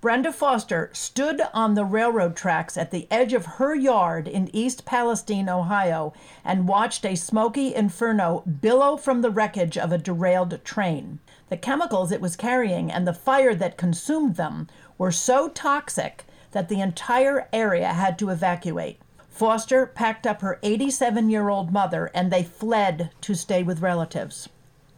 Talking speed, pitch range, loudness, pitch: 160 wpm, 175-240 Hz, -23 LUFS, 200 Hz